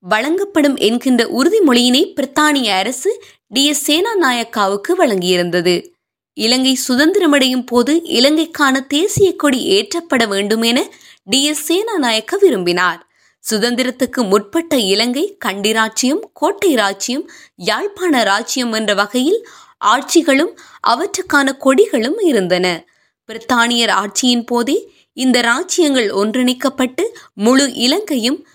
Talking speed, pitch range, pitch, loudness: 85 wpm, 230-335 Hz, 265 Hz, -14 LUFS